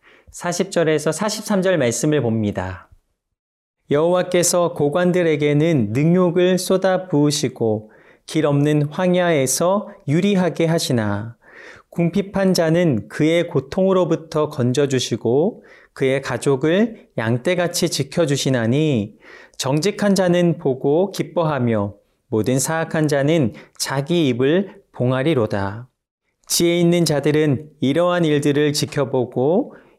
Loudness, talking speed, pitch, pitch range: -19 LUFS, 240 characters per minute, 155 Hz, 130-175 Hz